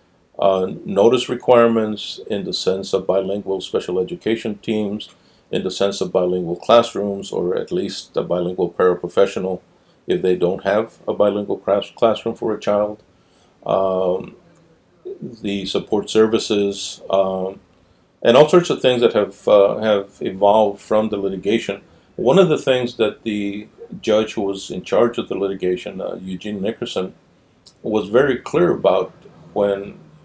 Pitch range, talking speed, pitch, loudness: 95-110 Hz, 145 wpm, 100 Hz, -19 LUFS